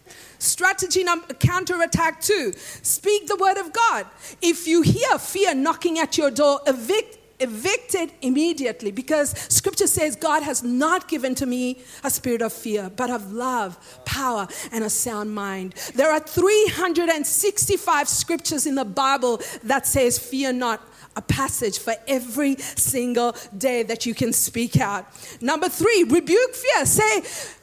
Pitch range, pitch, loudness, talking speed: 245-365 Hz, 295 Hz, -21 LUFS, 150 wpm